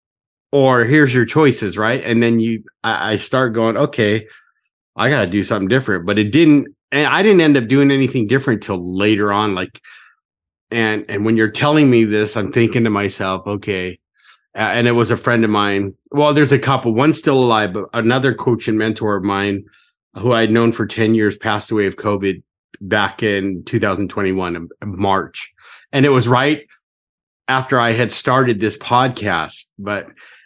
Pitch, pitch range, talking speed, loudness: 115 Hz, 105-130 Hz, 185 wpm, -16 LUFS